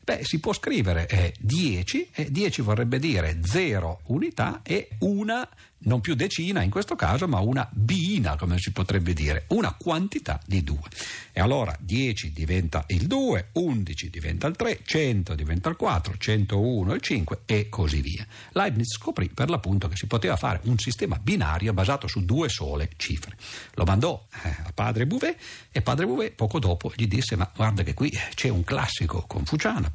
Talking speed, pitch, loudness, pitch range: 170 wpm, 100 Hz, -26 LUFS, 90-125 Hz